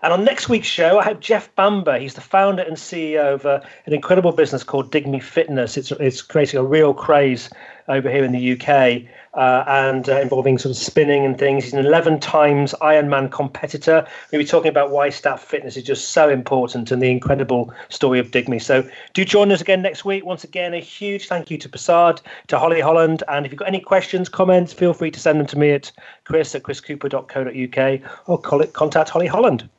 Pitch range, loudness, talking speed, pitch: 135-170 Hz, -18 LUFS, 215 wpm, 150 Hz